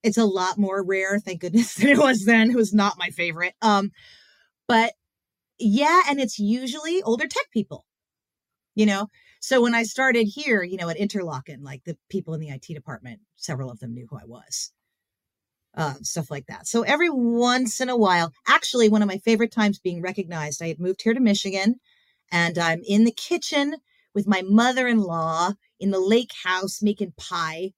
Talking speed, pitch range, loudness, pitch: 190 wpm, 175-230 Hz, -22 LUFS, 205 Hz